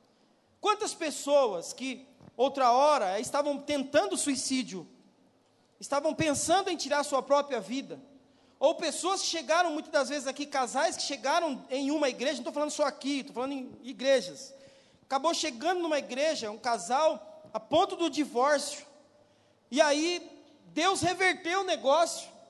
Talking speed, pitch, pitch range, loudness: 145 wpm, 290 Hz, 265-315 Hz, -29 LUFS